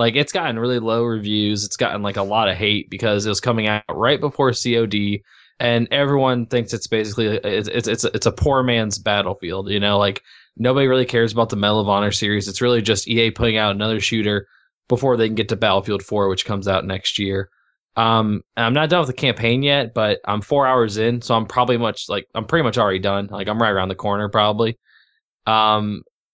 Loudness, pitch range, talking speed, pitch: -19 LUFS, 100-120 Hz, 225 wpm, 110 Hz